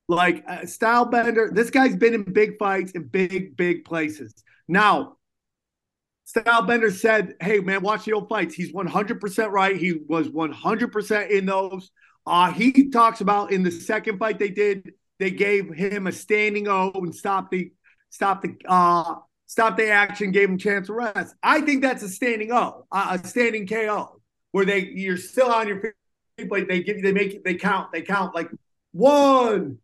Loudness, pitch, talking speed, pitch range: -22 LUFS, 200 Hz, 190 wpm, 185-225 Hz